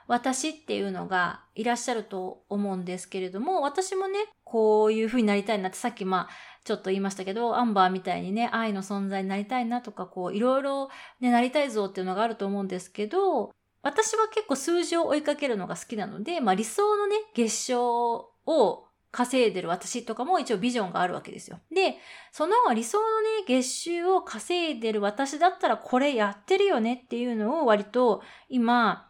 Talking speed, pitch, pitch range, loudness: 390 characters per minute, 240 Hz, 205-310 Hz, -27 LUFS